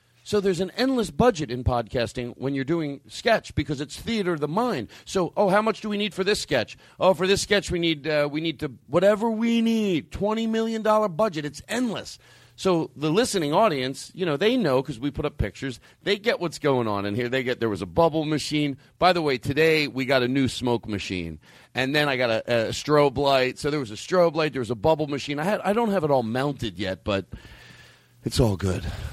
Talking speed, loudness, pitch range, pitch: 235 wpm, -24 LUFS, 125-190 Hz, 150 Hz